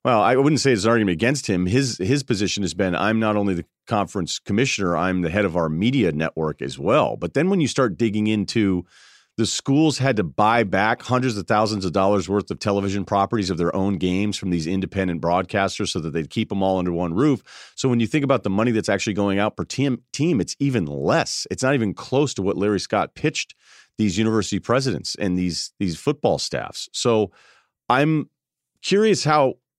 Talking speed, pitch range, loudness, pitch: 215 wpm, 95-125 Hz, -21 LUFS, 105 Hz